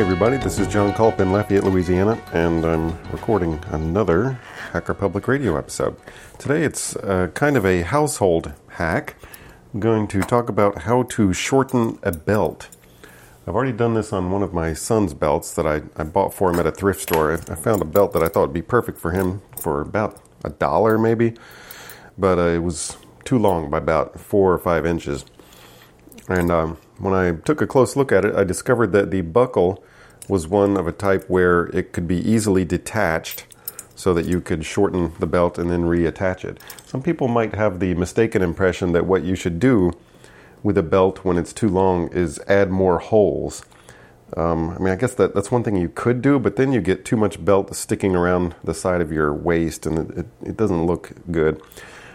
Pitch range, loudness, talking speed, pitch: 85-105 Hz, -20 LUFS, 205 wpm, 95 Hz